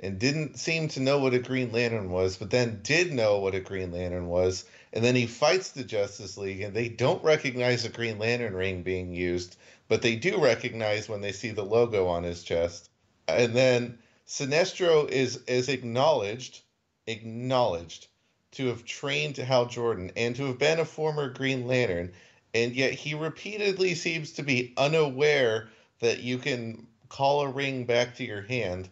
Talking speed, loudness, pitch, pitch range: 180 wpm, -27 LUFS, 120 Hz, 105-135 Hz